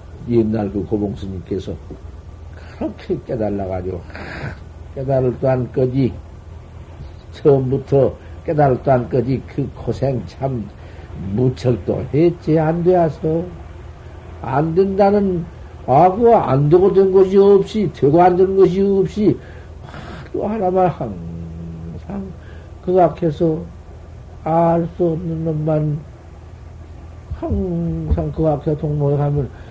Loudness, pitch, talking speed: -17 LUFS, 130 Hz, 205 characters per minute